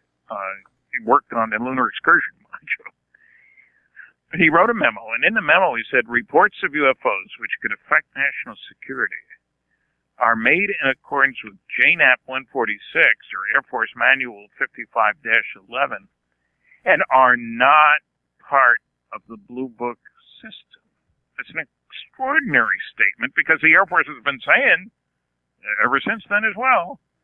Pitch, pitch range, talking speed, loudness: 135 Hz, 115-190 Hz, 140 wpm, -18 LUFS